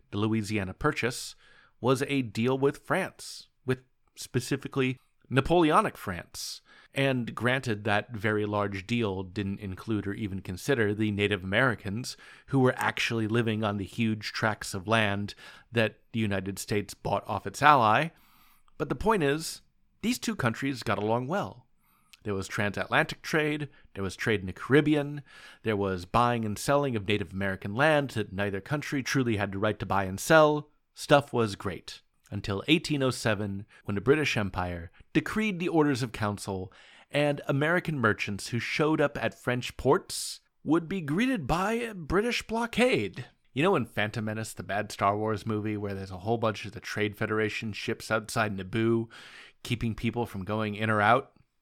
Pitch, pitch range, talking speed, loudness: 115 Hz, 105-140 Hz, 165 wpm, -29 LUFS